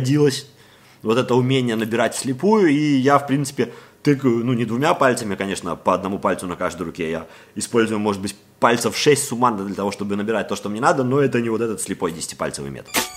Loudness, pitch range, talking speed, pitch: -20 LUFS, 100-135 Hz, 205 wpm, 120 Hz